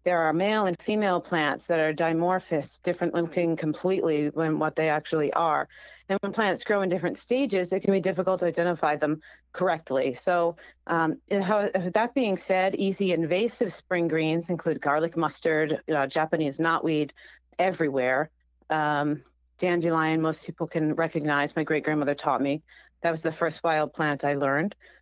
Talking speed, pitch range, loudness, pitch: 170 wpm, 155-185 Hz, -26 LUFS, 165 Hz